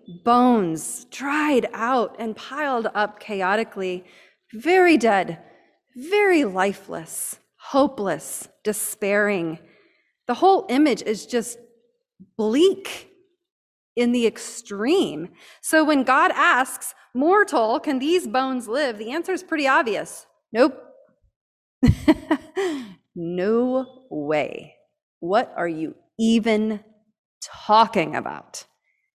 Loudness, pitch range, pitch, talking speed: -21 LUFS, 215-310 Hz, 245 Hz, 95 wpm